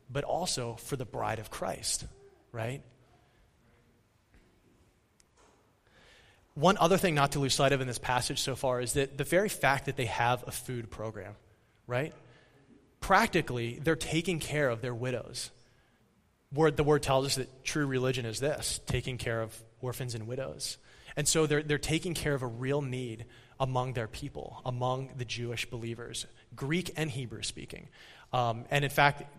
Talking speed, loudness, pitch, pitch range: 165 wpm, -31 LUFS, 130 Hz, 120-145 Hz